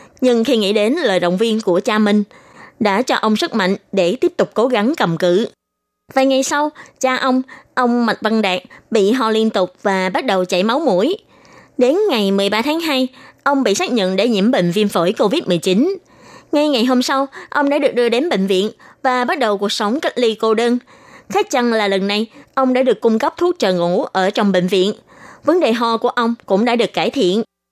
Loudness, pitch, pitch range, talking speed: -16 LUFS, 230 Hz, 200-265 Hz, 225 wpm